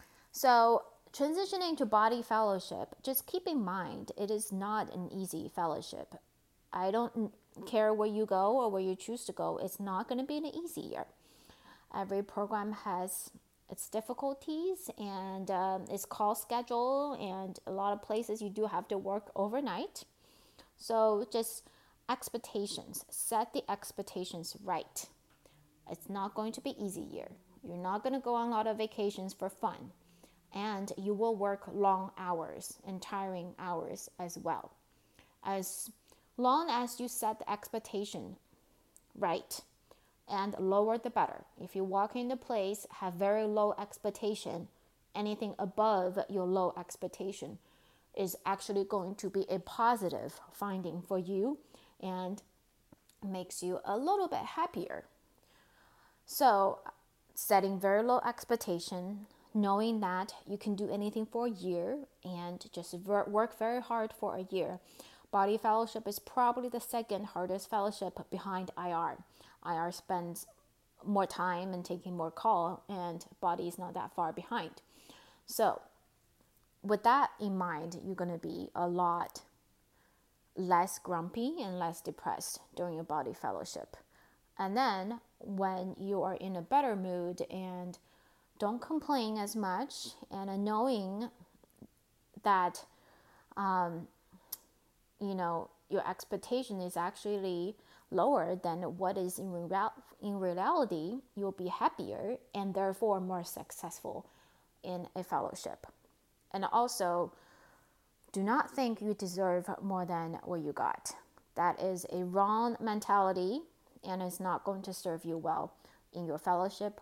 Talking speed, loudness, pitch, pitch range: 140 wpm, -36 LUFS, 200 Hz, 185-220 Hz